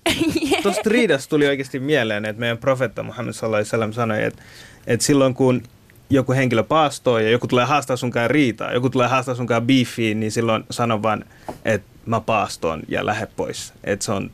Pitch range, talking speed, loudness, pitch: 115-140 Hz, 180 wpm, -20 LUFS, 125 Hz